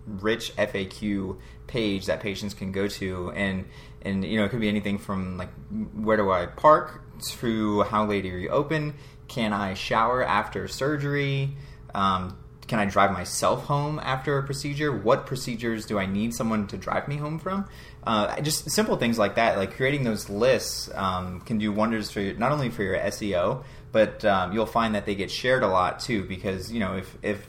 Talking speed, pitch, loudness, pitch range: 195 wpm, 110 Hz, -26 LUFS, 100-130 Hz